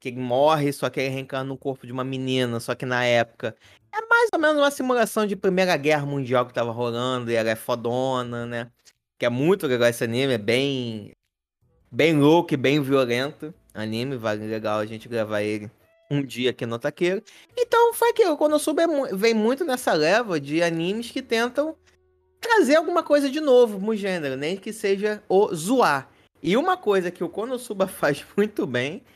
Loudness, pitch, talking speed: -23 LUFS, 145 Hz, 190 wpm